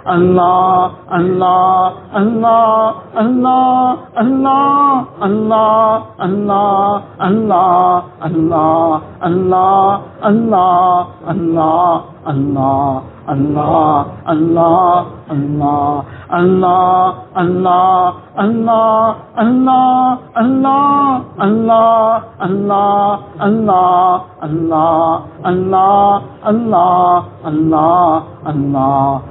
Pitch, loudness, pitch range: 185 Hz, -12 LUFS, 165-220 Hz